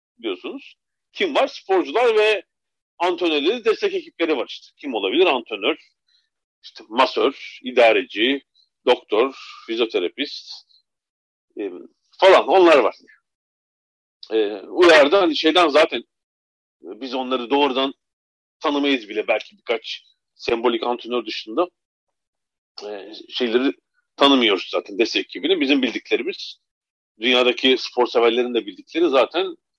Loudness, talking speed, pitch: -19 LUFS, 105 wpm, 275 Hz